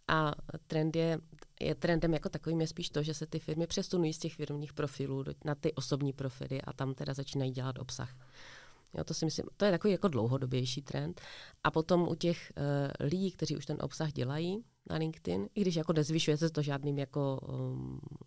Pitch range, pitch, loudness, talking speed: 140-165 Hz, 155 Hz, -35 LUFS, 200 wpm